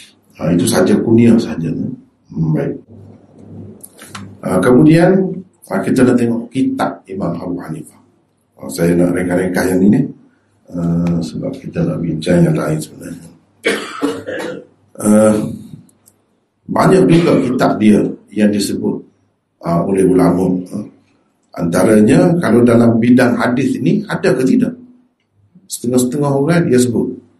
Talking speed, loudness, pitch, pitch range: 120 wpm, -14 LUFS, 105 Hz, 90-125 Hz